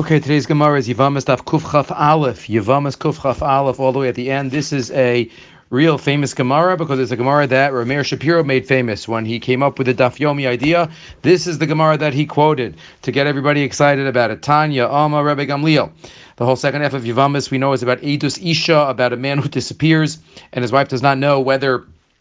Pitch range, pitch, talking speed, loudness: 130-150 Hz, 140 Hz, 220 wpm, -16 LUFS